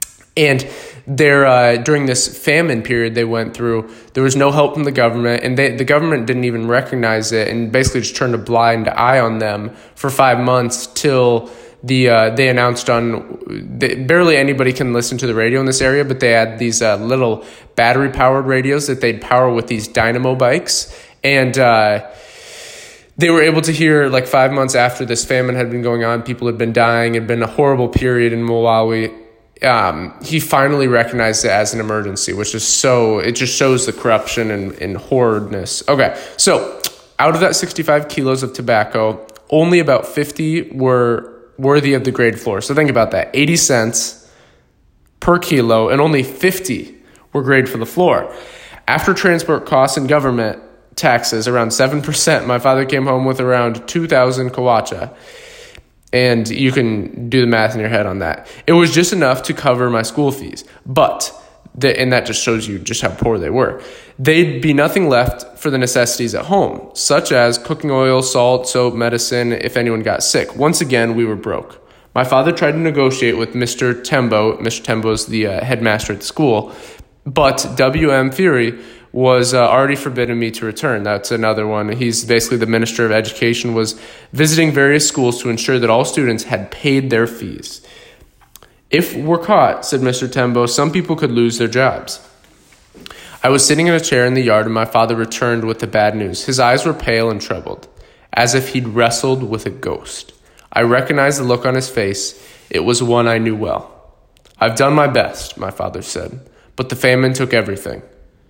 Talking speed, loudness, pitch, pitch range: 185 wpm, -15 LUFS, 125 Hz, 115-135 Hz